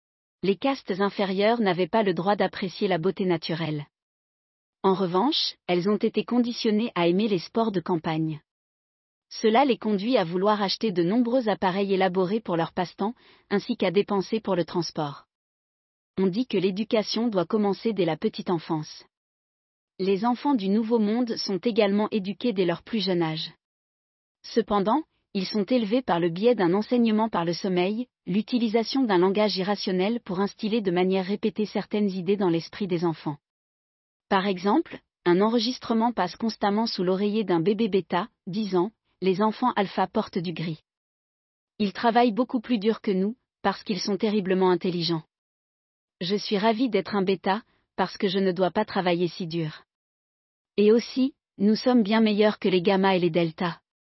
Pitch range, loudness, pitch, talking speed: 180-225 Hz, -25 LUFS, 200 Hz, 165 wpm